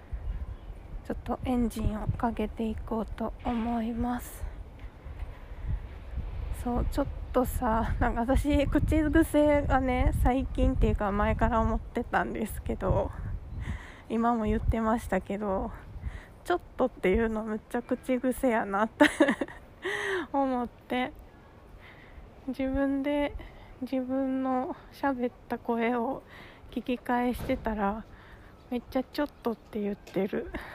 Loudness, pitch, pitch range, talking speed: -30 LUFS, 240 Hz, 210-265 Hz, 240 characters per minute